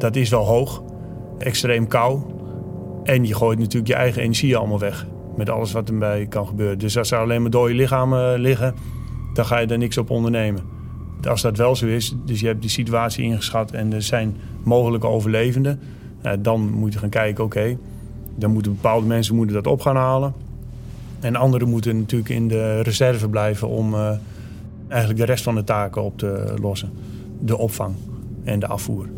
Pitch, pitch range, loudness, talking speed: 115 Hz, 105-120 Hz, -20 LUFS, 185 wpm